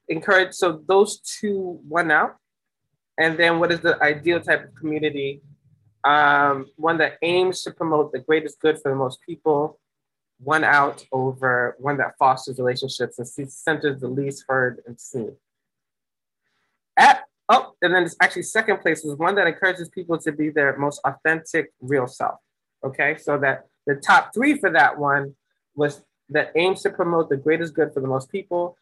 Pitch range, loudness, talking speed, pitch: 140-170 Hz, -21 LUFS, 175 wpm, 150 Hz